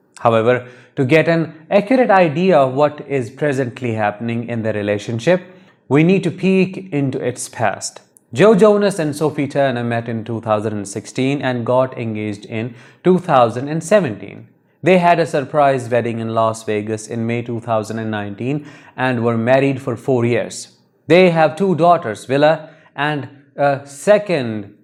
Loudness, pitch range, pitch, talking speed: -17 LUFS, 115-160 Hz, 135 Hz, 145 wpm